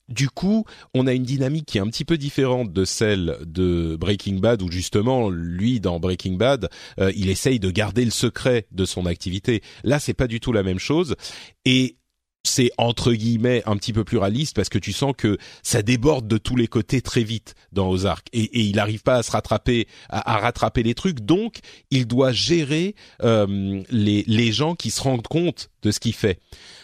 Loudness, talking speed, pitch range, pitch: -22 LUFS, 210 wpm, 100-130 Hz, 115 Hz